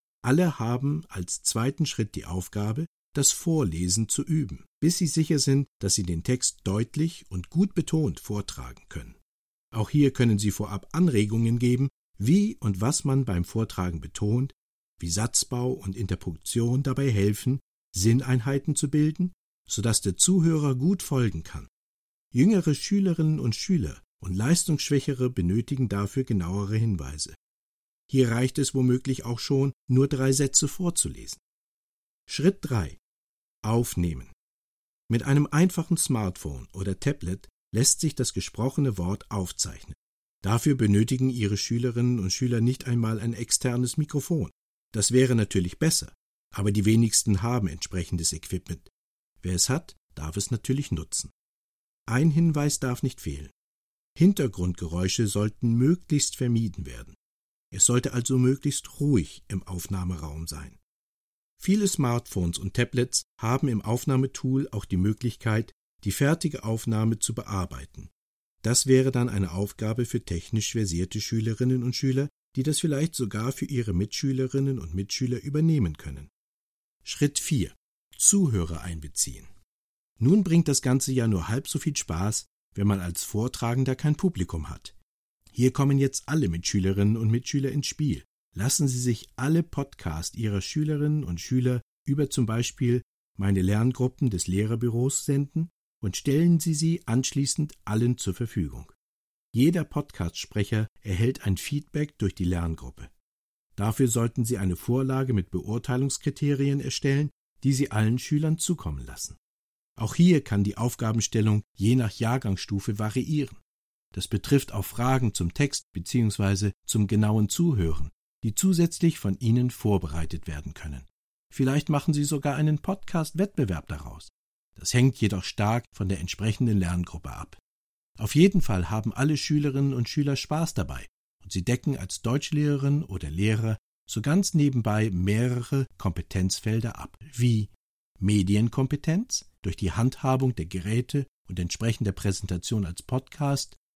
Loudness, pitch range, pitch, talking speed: -26 LUFS, 95-140 Hz, 120 Hz, 135 wpm